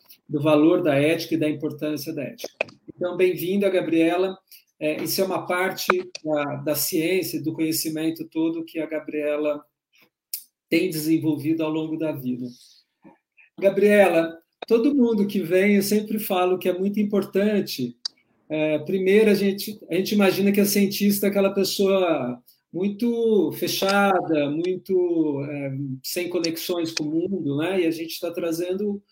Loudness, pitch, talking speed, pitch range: -23 LUFS, 175 Hz, 150 wpm, 155-195 Hz